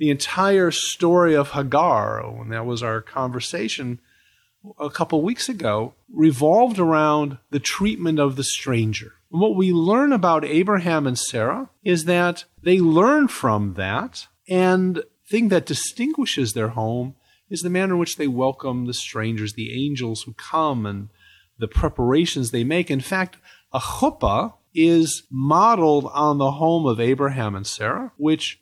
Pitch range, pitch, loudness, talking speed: 125-175 Hz, 150 Hz, -21 LUFS, 155 wpm